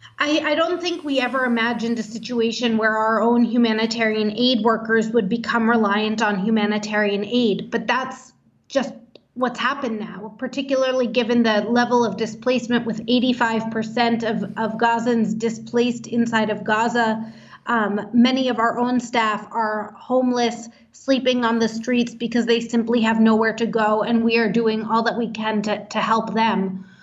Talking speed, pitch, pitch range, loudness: 165 wpm, 230 Hz, 220-245 Hz, -20 LUFS